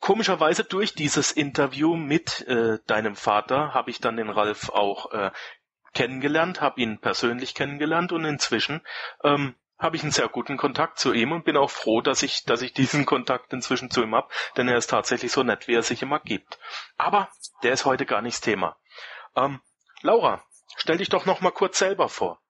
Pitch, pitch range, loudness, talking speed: 145 Hz, 125-165 Hz, -24 LUFS, 195 wpm